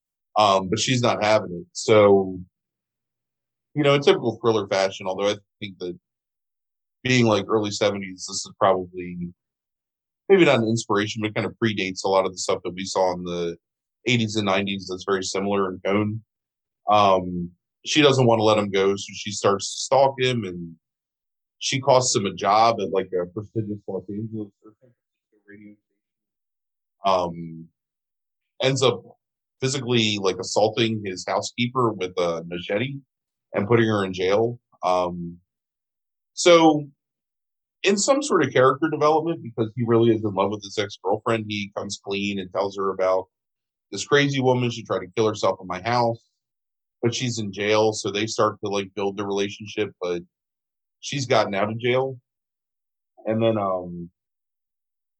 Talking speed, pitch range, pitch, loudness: 165 wpm, 95-115 Hz, 105 Hz, -22 LUFS